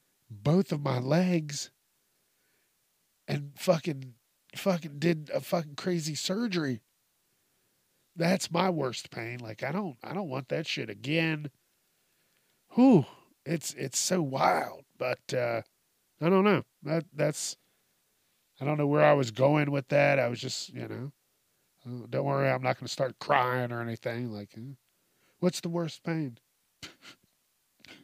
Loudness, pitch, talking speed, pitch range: -29 LUFS, 145 Hz, 145 wpm, 130-170 Hz